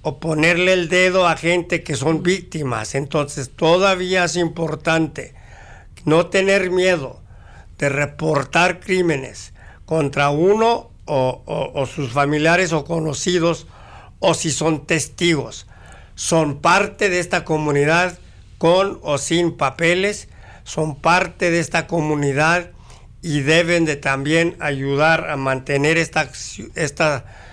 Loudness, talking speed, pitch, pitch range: -18 LUFS, 120 wpm, 155 Hz, 135-170 Hz